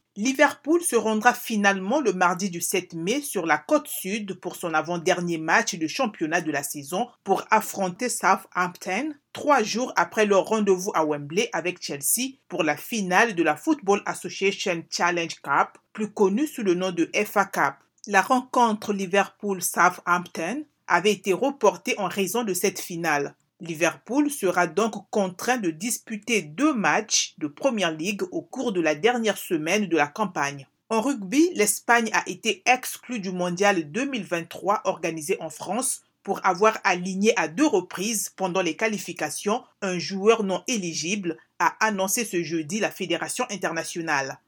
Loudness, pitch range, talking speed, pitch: -24 LUFS, 175-230 Hz, 155 wpm, 195 Hz